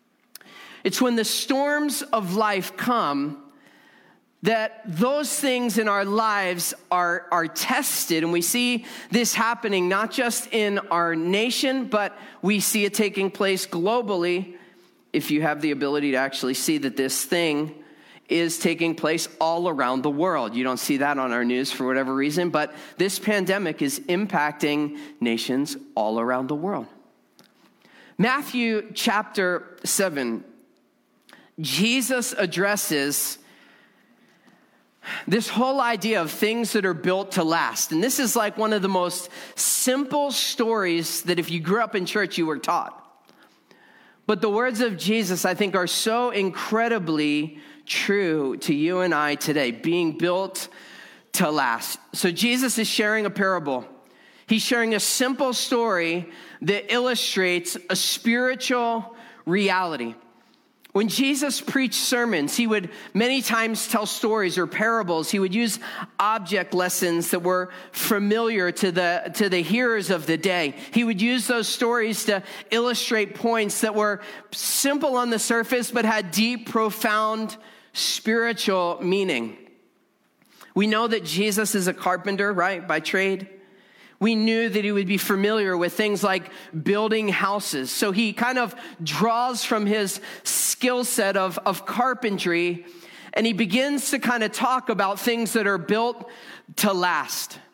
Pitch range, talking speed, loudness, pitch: 175-230 Hz, 145 wpm, -23 LUFS, 200 Hz